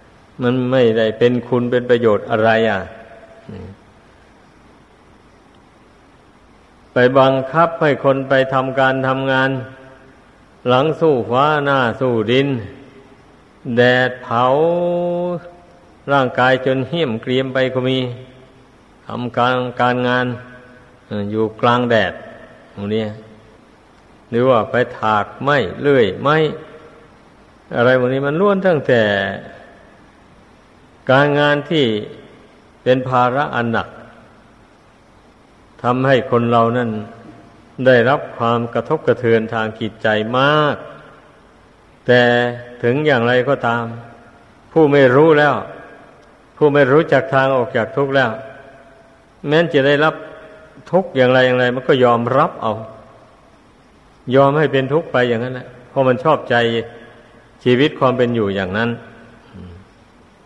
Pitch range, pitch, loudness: 115-135 Hz, 125 Hz, -16 LUFS